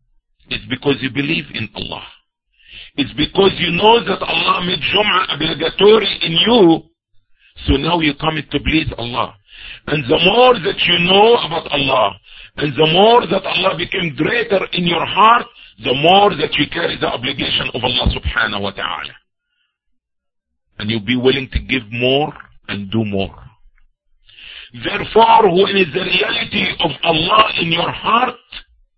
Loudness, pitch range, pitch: -15 LUFS, 130-195 Hz, 160 Hz